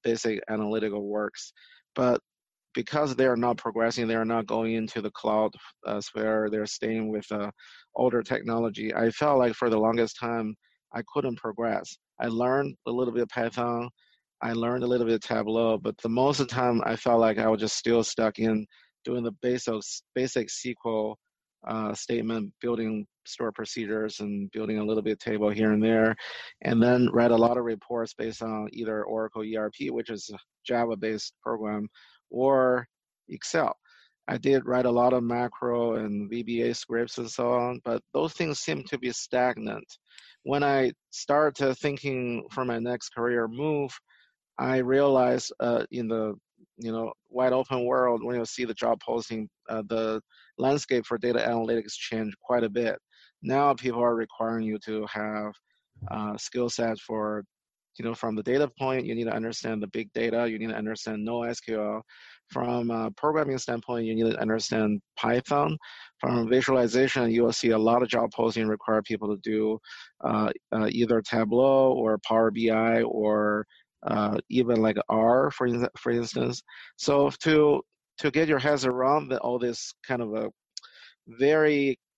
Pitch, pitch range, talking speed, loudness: 115 Hz, 110-125 Hz, 170 wpm, -27 LUFS